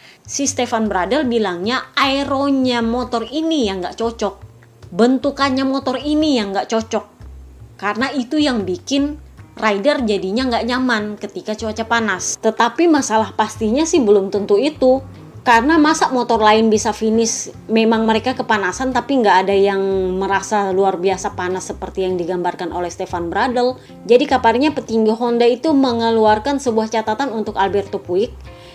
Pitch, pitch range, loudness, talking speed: 225 Hz, 200-255 Hz, -17 LUFS, 140 wpm